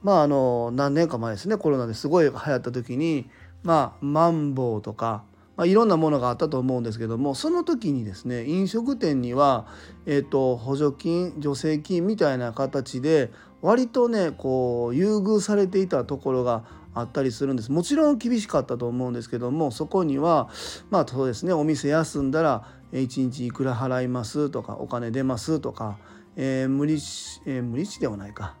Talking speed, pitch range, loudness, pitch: 355 characters per minute, 125-160 Hz, -24 LUFS, 135 Hz